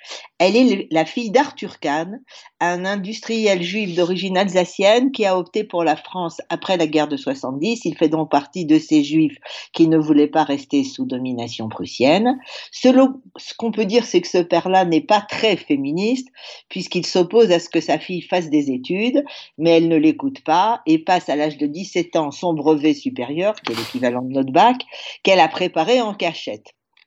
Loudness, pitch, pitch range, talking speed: -18 LUFS, 180 Hz, 160-230 Hz, 190 wpm